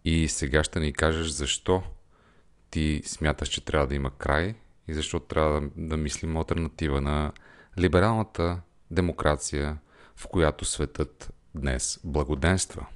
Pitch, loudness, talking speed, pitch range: 80 Hz, -28 LUFS, 125 wpm, 75-85 Hz